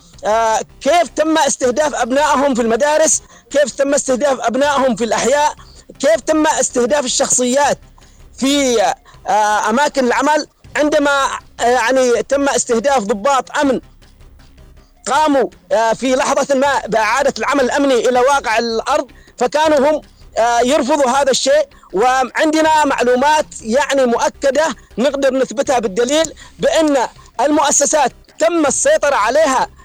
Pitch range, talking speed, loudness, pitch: 245-295 Hz, 115 wpm, -14 LUFS, 275 Hz